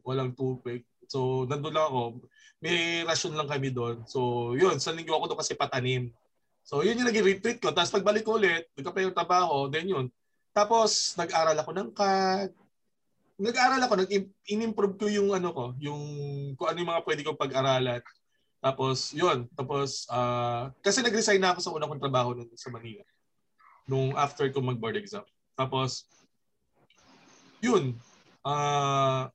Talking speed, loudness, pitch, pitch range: 155 wpm, -28 LUFS, 145 Hz, 130-190 Hz